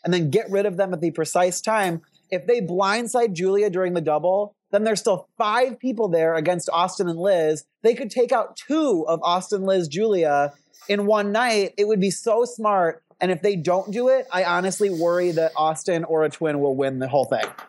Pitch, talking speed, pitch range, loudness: 185 Hz, 215 wpm, 170-210 Hz, -22 LUFS